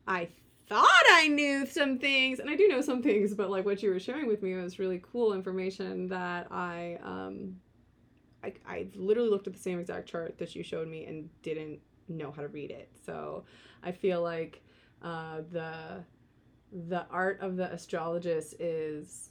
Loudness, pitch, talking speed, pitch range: -30 LUFS, 185 Hz, 185 wpm, 165-205 Hz